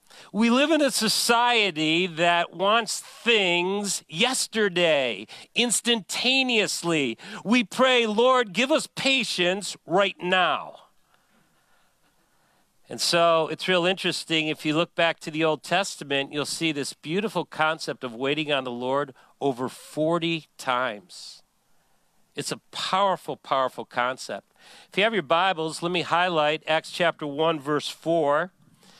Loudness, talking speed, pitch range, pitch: -24 LUFS, 130 wpm, 155-205 Hz, 170 Hz